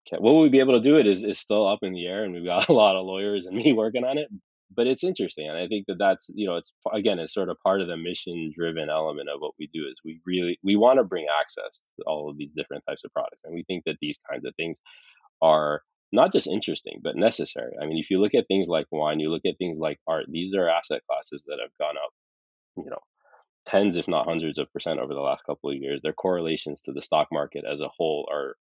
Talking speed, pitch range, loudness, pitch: 270 wpm, 80-100 Hz, -25 LUFS, 90 Hz